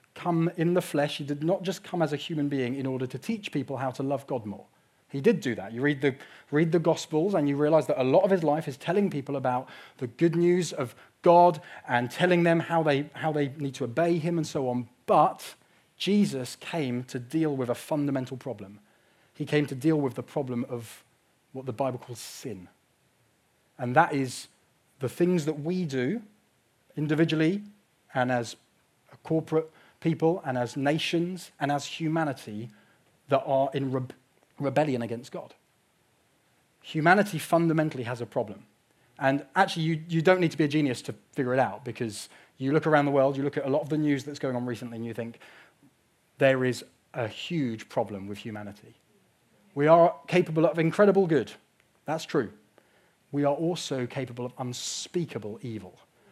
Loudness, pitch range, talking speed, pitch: -27 LUFS, 125-165 Hz, 190 wpm, 145 Hz